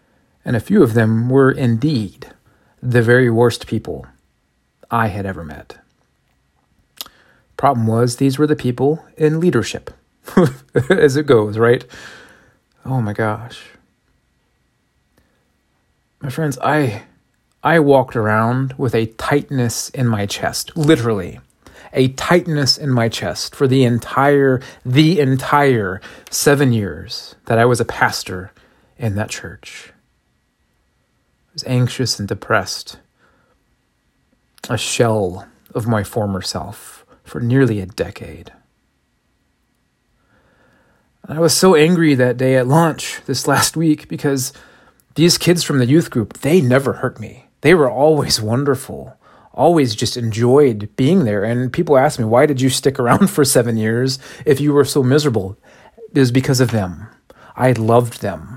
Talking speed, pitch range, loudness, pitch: 135 wpm, 115-145 Hz, -16 LUFS, 125 Hz